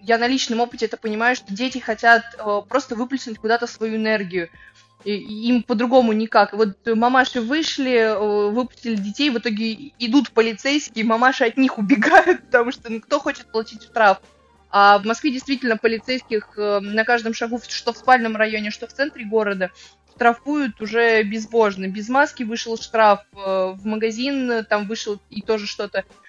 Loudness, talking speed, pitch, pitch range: -20 LUFS, 165 wpm, 230 Hz, 215-250 Hz